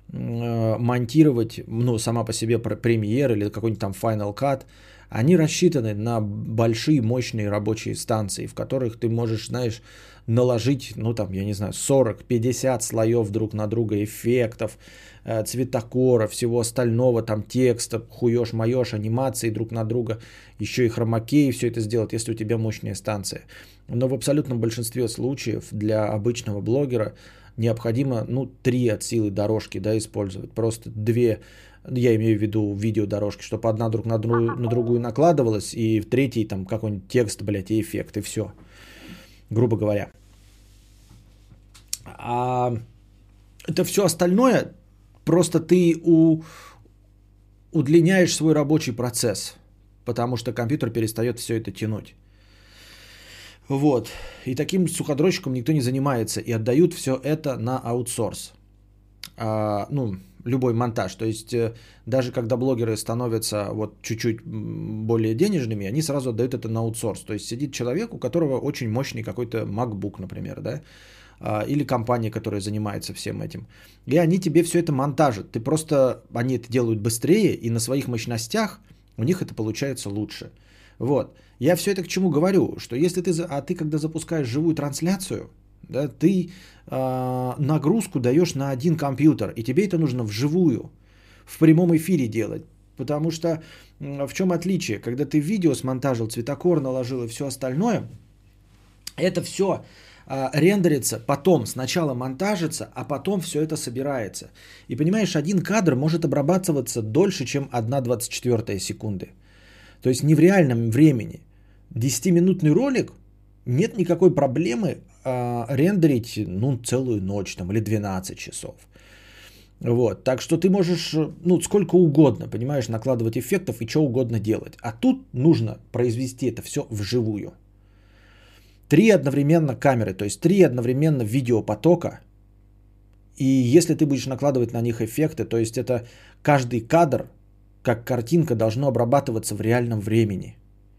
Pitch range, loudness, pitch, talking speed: 110-140 Hz, -23 LUFS, 120 Hz, 140 wpm